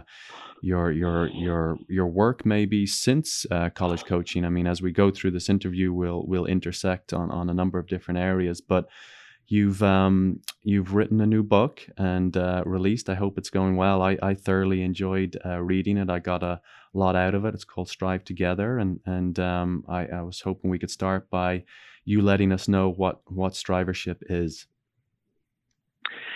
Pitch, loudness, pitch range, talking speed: 95 Hz, -25 LUFS, 90-100 Hz, 185 wpm